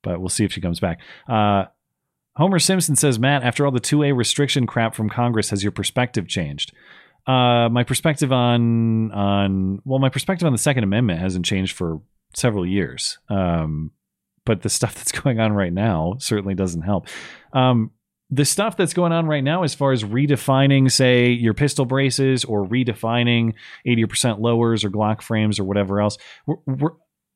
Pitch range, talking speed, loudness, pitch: 100-135 Hz, 180 wpm, -20 LUFS, 120 Hz